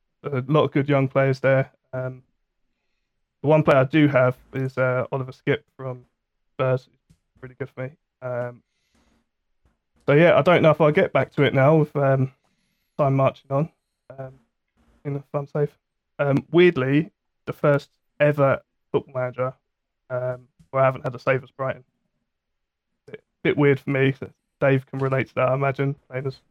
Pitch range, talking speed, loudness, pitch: 130-145 Hz, 170 wpm, -22 LUFS, 135 Hz